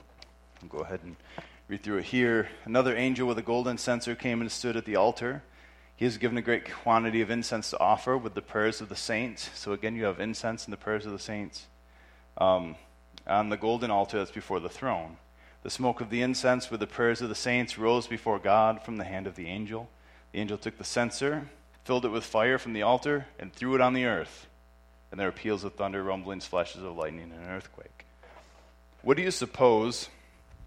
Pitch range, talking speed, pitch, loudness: 80-120 Hz, 215 wpm, 110 Hz, -29 LUFS